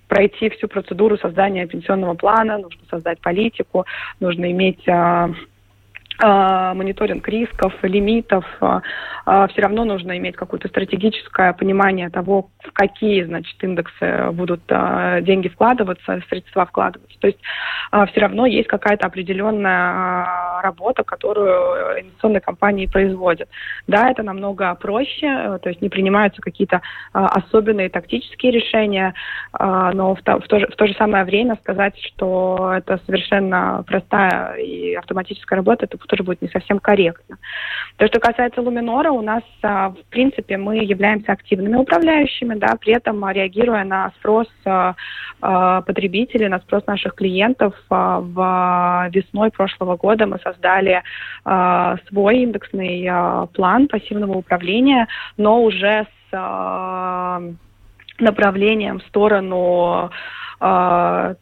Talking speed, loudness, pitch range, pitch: 125 wpm, -18 LUFS, 185-215 Hz, 195 Hz